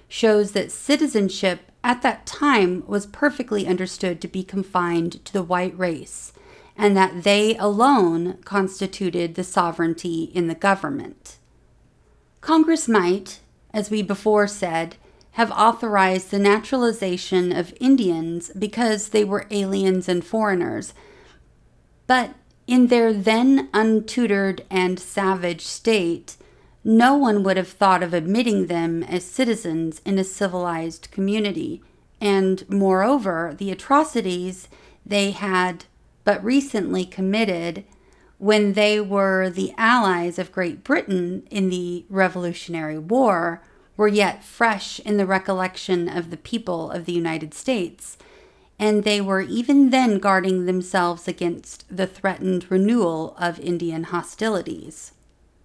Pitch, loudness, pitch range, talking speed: 195 Hz, -21 LUFS, 180-215 Hz, 125 wpm